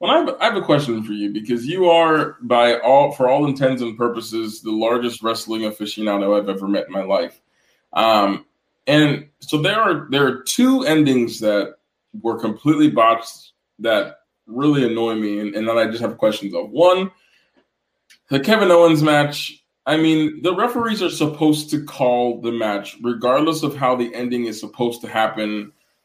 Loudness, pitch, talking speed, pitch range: -18 LUFS, 125 Hz, 175 wpm, 115-155 Hz